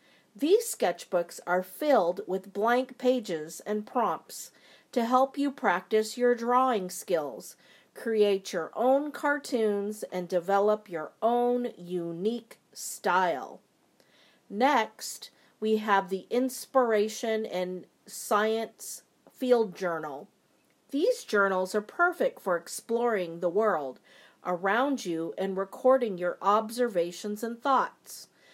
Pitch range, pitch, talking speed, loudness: 185-250 Hz, 215 Hz, 105 wpm, -28 LUFS